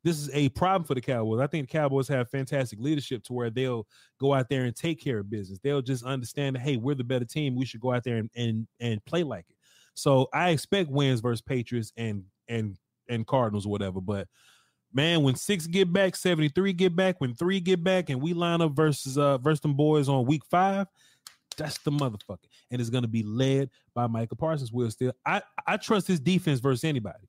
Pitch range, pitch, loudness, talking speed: 120-160 Hz, 135 Hz, -28 LUFS, 230 wpm